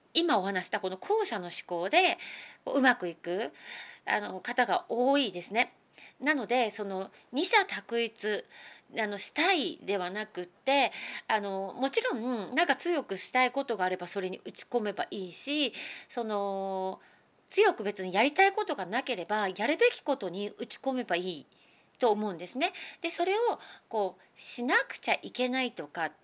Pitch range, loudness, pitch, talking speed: 195-285 Hz, -30 LUFS, 235 Hz, 305 characters per minute